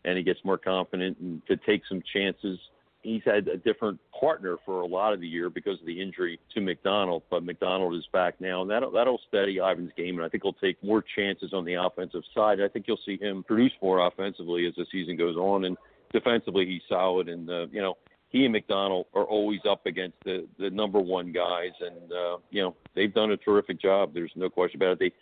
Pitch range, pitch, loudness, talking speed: 90-100 Hz, 95 Hz, -28 LUFS, 230 wpm